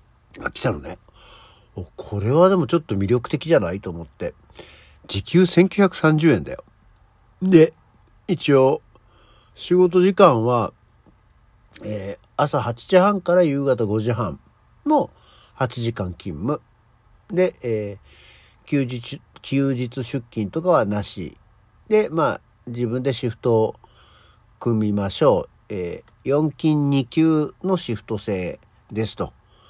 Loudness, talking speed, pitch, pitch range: -21 LUFS, 190 characters per minute, 115 Hz, 105-145 Hz